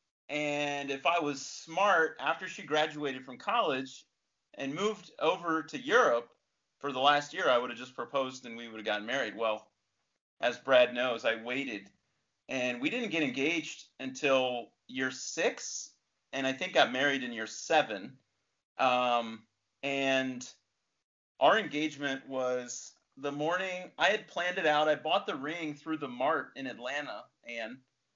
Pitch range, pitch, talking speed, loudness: 125-150 Hz, 135 Hz, 160 wpm, -31 LUFS